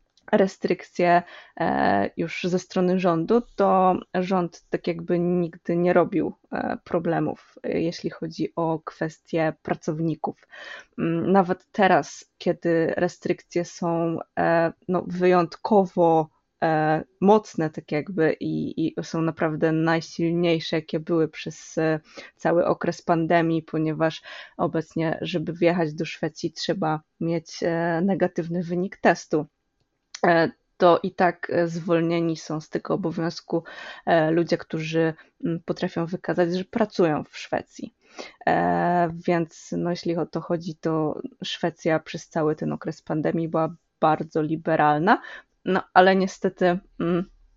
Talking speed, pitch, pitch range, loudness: 105 wpm, 170 Hz, 160-180 Hz, -24 LUFS